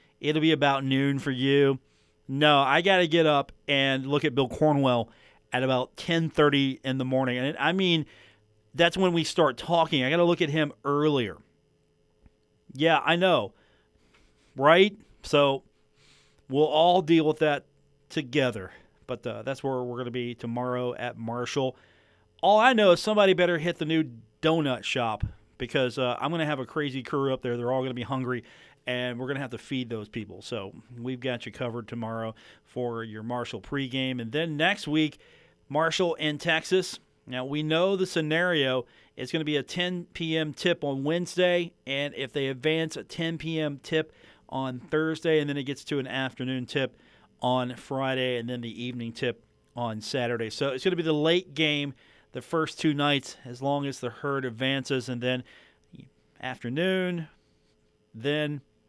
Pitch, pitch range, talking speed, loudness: 140 Hz, 125-155 Hz, 175 wpm, -27 LUFS